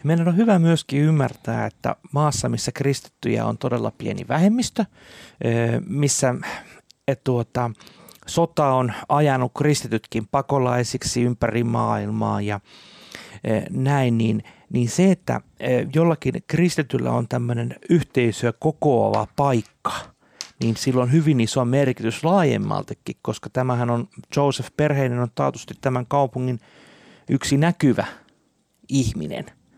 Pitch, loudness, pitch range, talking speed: 130 Hz, -22 LUFS, 120-145 Hz, 110 wpm